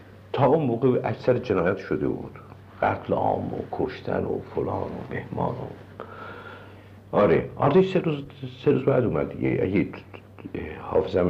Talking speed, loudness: 125 wpm, -25 LUFS